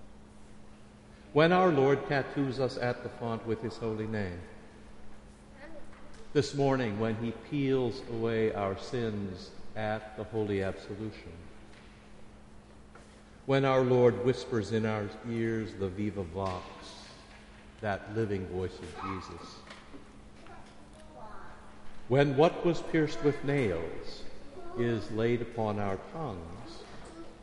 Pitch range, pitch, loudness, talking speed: 105-130 Hz, 110 Hz, -31 LUFS, 110 wpm